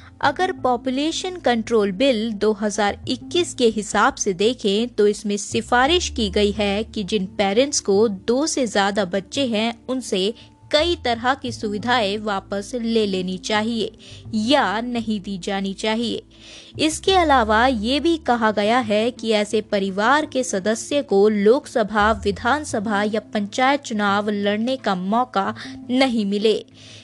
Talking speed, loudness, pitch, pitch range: 135 wpm, -20 LUFS, 220 Hz, 205-255 Hz